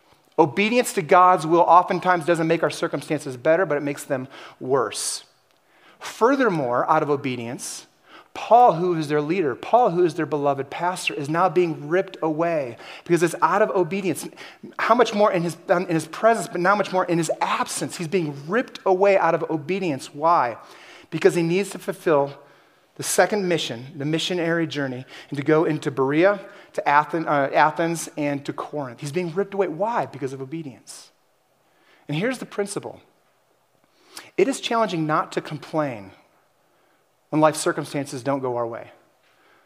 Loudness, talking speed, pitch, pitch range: -22 LUFS, 165 wpm, 165 Hz, 150-185 Hz